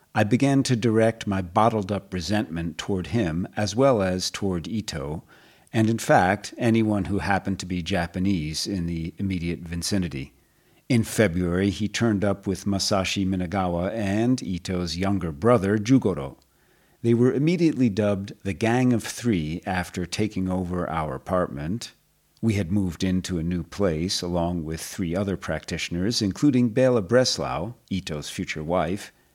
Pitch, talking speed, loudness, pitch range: 100 Hz, 145 wpm, -24 LUFS, 90-115 Hz